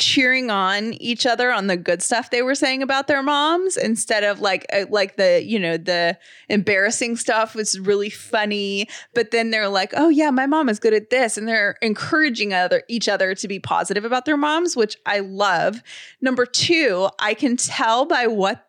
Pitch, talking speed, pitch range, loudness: 225 Hz, 195 wpm, 200-260 Hz, -19 LUFS